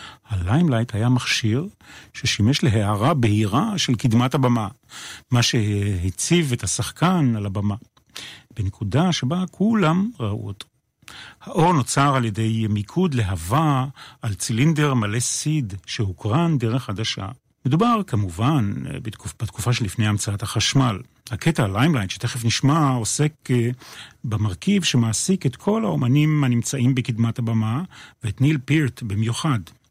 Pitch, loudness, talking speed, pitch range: 125 Hz, -21 LUFS, 110 wpm, 110-150 Hz